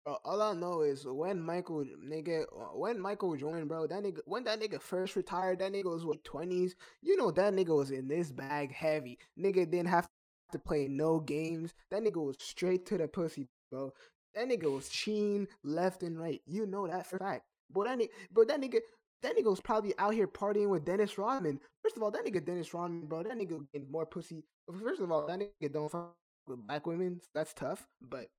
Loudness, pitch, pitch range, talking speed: -36 LUFS, 175 Hz, 155-200 Hz, 220 wpm